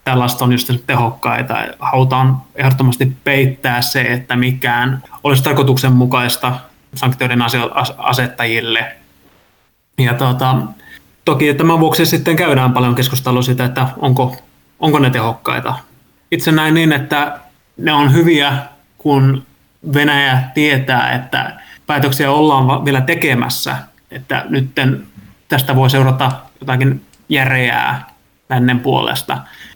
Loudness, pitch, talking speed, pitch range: -14 LUFS, 130 Hz, 105 wpm, 125-145 Hz